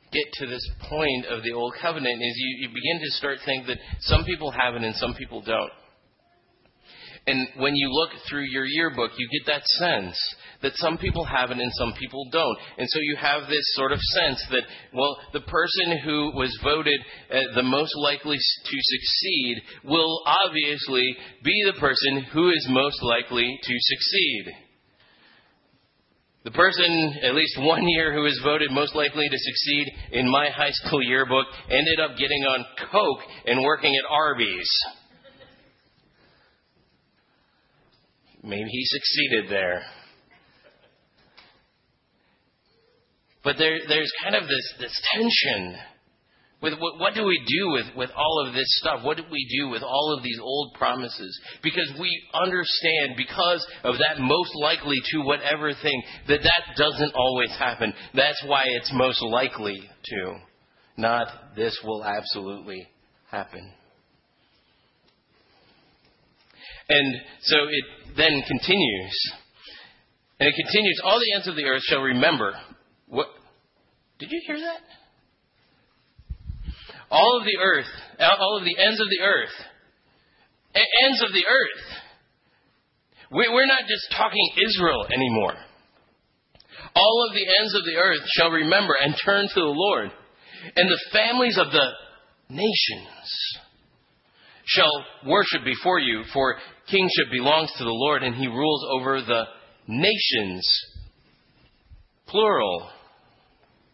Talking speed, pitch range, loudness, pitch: 140 wpm, 130-160 Hz, -22 LUFS, 145 Hz